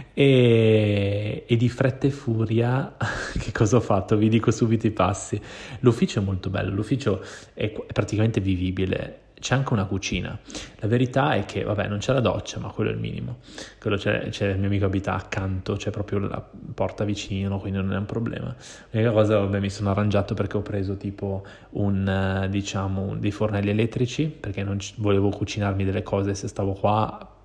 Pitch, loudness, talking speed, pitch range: 105 Hz, -24 LUFS, 190 wpm, 100-115 Hz